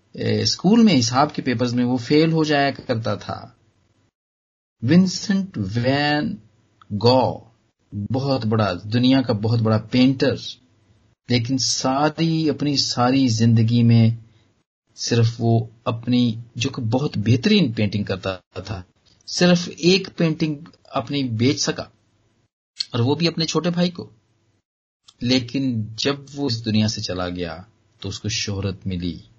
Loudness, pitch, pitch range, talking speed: -20 LUFS, 115 Hz, 110-140 Hz, 130 wpm